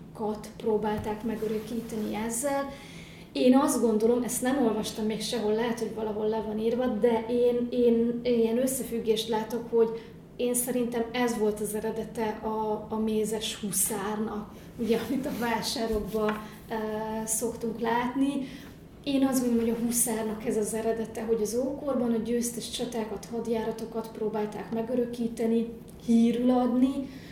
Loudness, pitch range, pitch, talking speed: -28 LUFS, 220-240 Hz, 230 Hz, 135 wpm